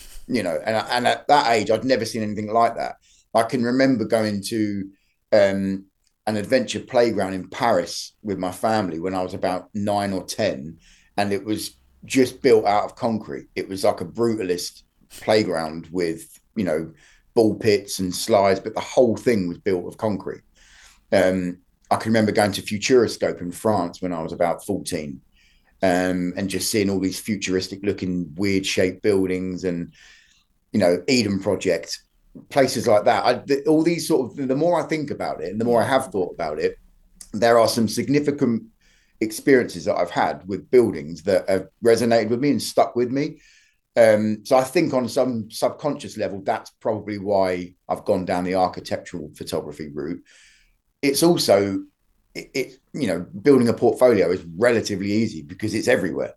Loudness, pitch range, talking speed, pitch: -22 LUFS, 95-120 Hz, 175 wpm, 105 Hz